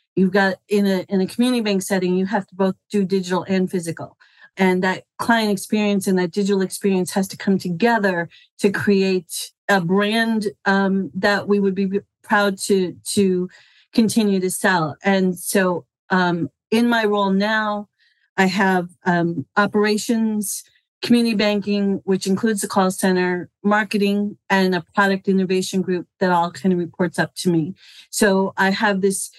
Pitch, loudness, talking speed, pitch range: 195 Hz, -20 LUFS, 165 wpm, 185-205 Hz